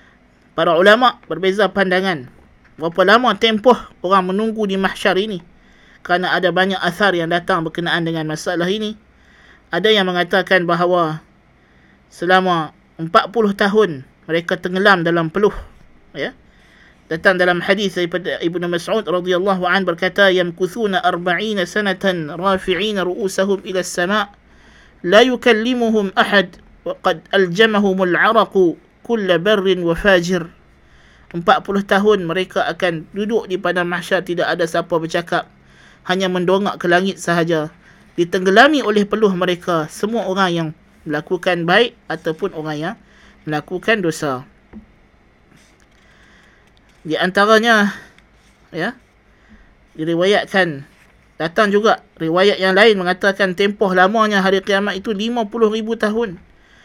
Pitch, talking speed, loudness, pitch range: 185 Hz, 115 wpm, -16 LUFS, 170-205 Hz